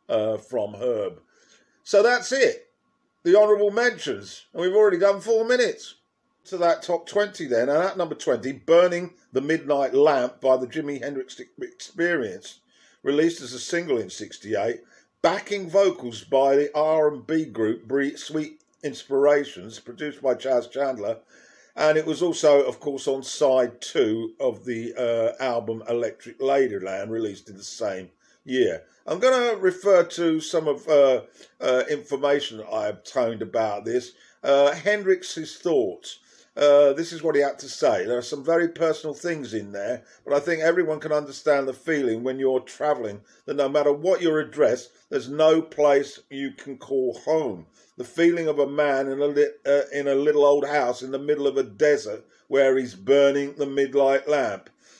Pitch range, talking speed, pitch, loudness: 135-175 Hz, 170 wpm, 145 Hz, -23 LUFS